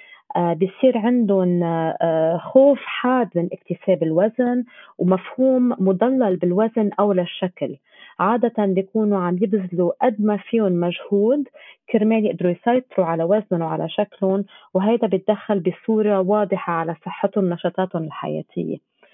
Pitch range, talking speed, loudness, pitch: 180-225 Hz, 115 wpm, -20 LUFS, 195 Hz